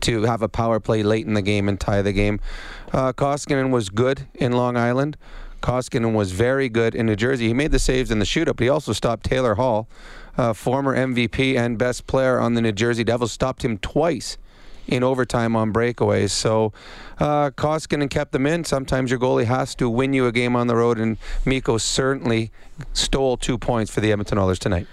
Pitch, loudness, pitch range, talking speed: 120 Hz, -21 LUFS, 110-130 Hz, 210 wpm